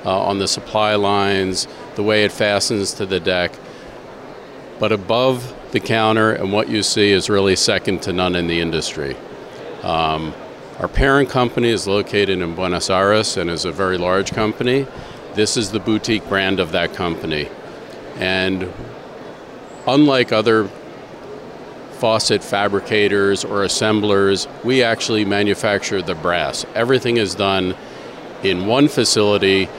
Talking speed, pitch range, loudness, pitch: 140 wpm, 95-110 Hz, -17 LUFS, 100 Hz